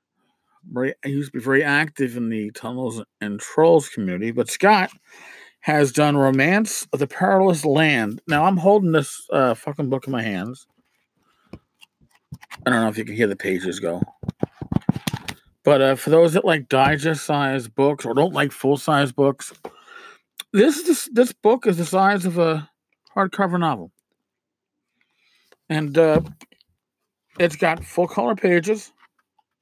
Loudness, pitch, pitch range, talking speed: -20 LUFS, 150 Hz, 130-180 Hz, 145 wpm